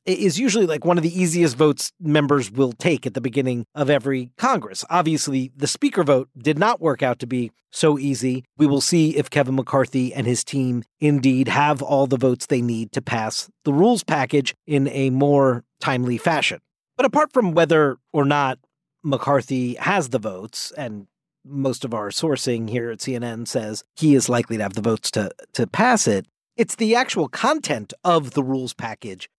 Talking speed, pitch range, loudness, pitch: 190 wpm, 125-155 Hz, -21 LUFS, 140 Hz